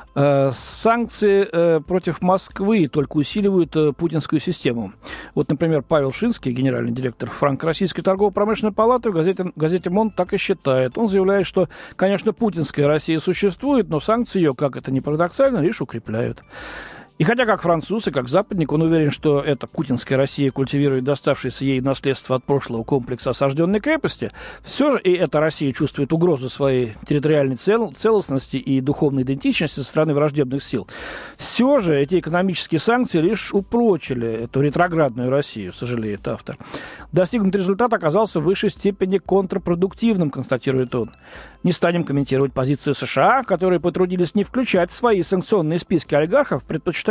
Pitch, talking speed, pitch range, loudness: 165 Hz, 150 wpm, 140-195 Hz, -20 LUFS